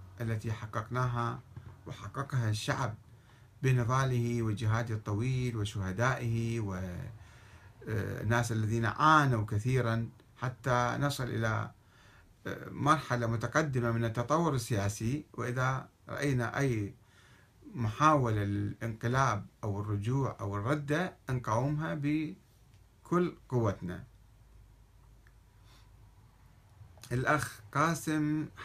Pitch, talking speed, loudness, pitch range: 120 Hz, 70 wpm, -32 LUFS, 105-130 Hz